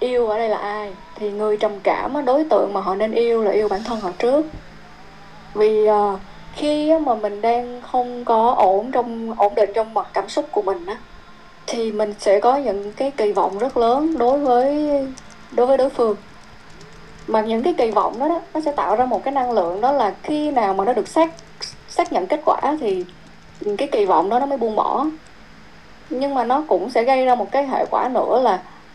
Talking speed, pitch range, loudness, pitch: 215 wpm, 210-275 Hz, -19 LUFS, 240 Hz